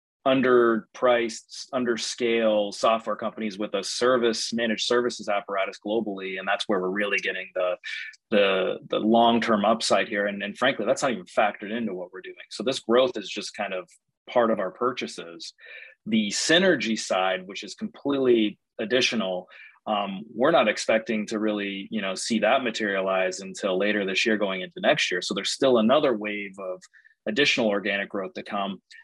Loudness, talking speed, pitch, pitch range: -25 LUFS, 170 wpm, 110 Hz, 100-120 Hz